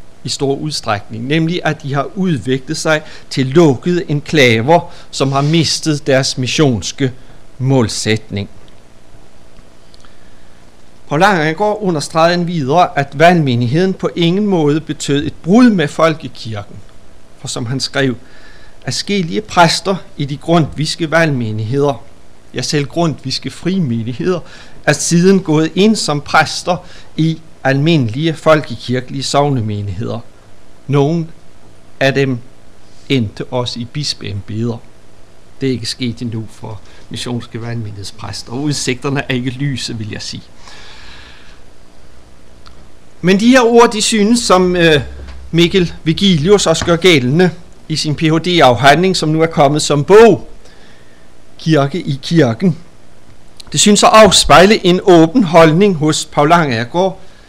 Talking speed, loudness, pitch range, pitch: 125 wpm, -13 LUFS, 120-170 Hz, 145 Hz